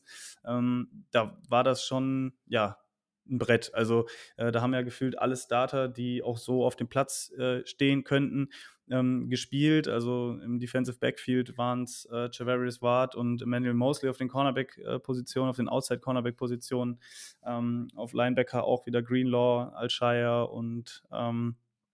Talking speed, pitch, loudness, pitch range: 155 wpm, 125 Hz, -30 LUFS, 120-130 Hz